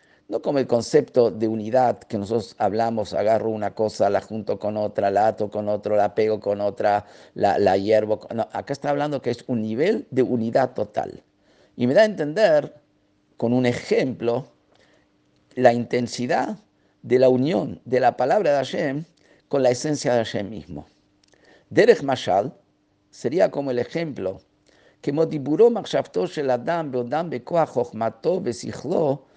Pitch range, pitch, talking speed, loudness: 105-140 Hz, 120 Hz, 145 wpm, -22 LUFS